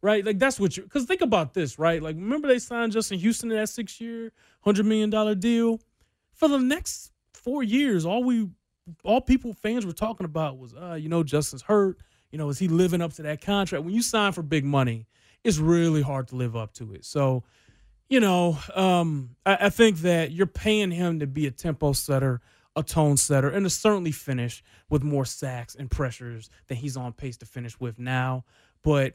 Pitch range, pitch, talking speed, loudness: 135-215 Hz, 165 Hz, 210 wpm, -25 LUFS